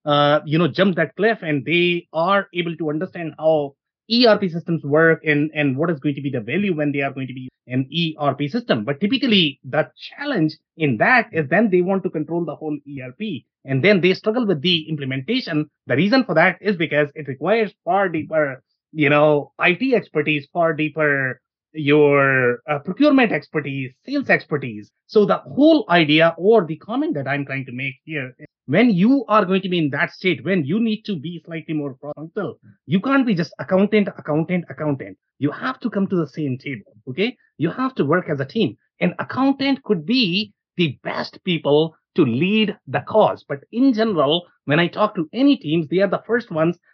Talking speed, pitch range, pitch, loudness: 200 wpm, 150-205 Hz, 165 Hz, -19 LUFS